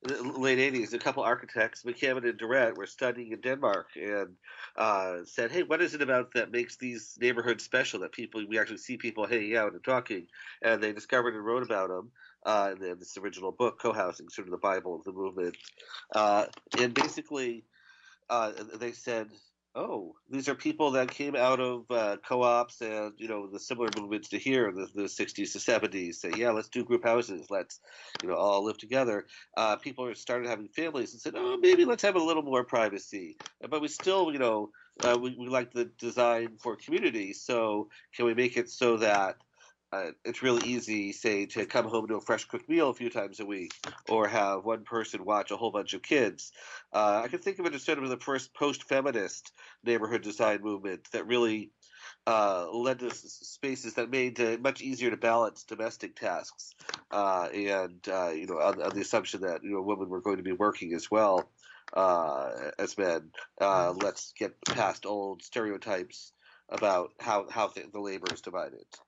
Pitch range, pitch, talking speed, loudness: 105-130 Hz, 120 Hz, 195 wpm, -31 LUFS